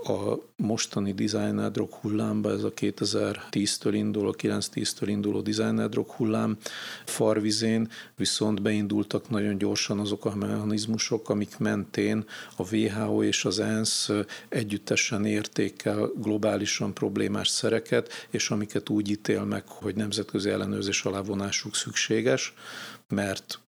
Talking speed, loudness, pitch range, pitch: 110 wpm, -28 LUFS, 105-110 Hz, 105 Hz